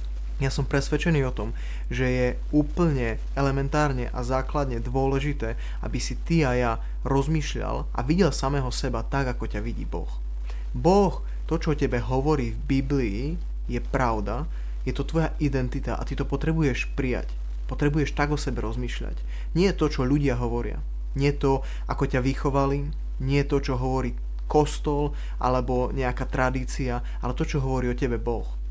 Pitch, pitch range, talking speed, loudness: 135 Hz, 120-145 Hz, 160 wpm, -26 LUFS